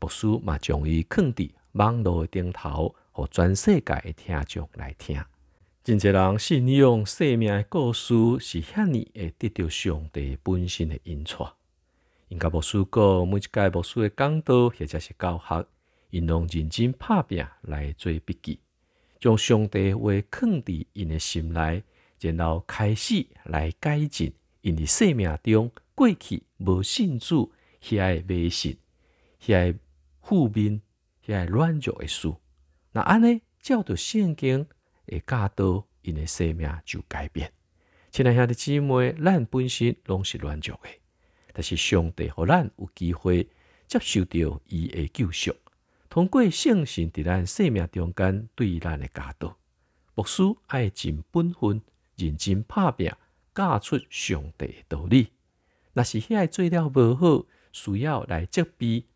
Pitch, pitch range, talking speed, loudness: 95 Hz, 80-120 Hz, 205 characters per minute, -25 LUFS